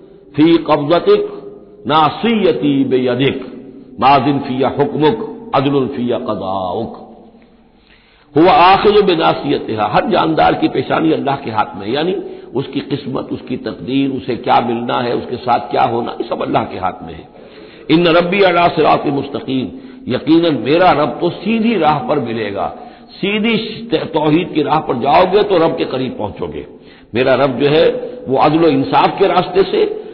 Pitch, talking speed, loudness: 170 Hz, 155 wpm, -14 LUFS